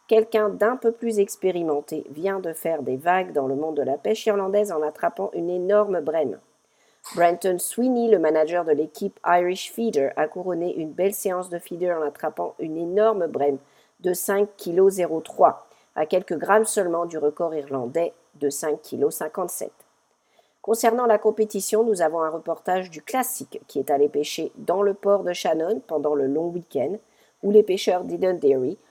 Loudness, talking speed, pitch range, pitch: -23 LUFS, 170 wpm, 160-210 Hz, 180 Hz